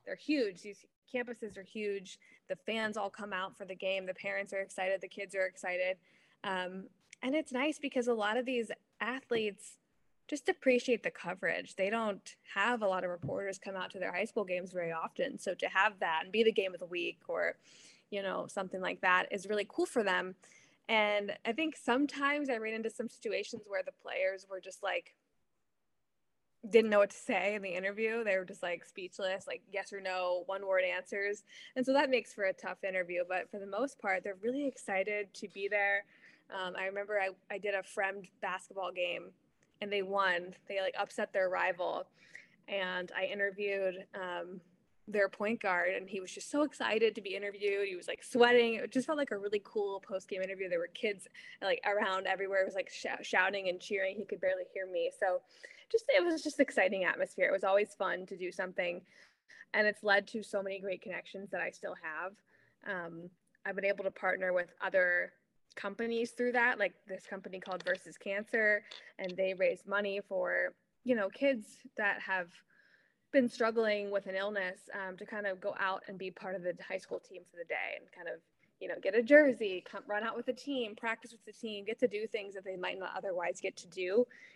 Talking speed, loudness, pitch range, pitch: 210 wpm, -35 LUFS, 190-230 Hz, 200 Hz